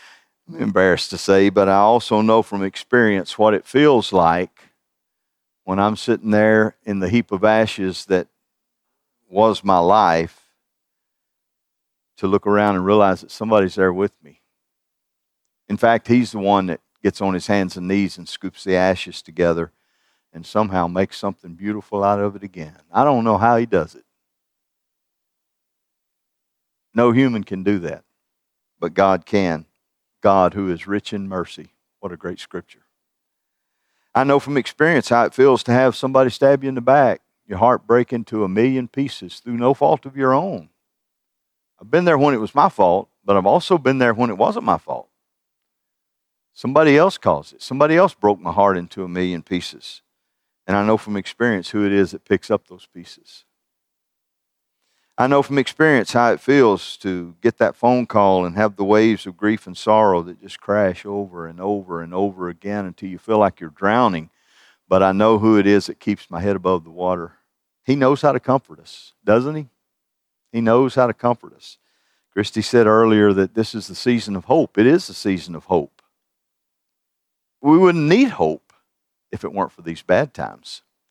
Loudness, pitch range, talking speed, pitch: -18 LUFS, 95-120 Hz, 185 wpm, 100 Hz